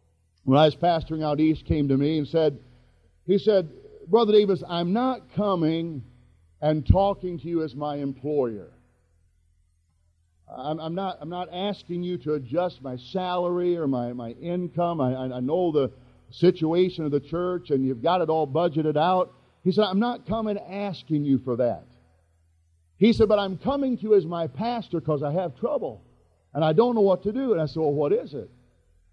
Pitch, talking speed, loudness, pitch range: 160 Hz, 190 wpm, -25 LUFS, 130-185 Hz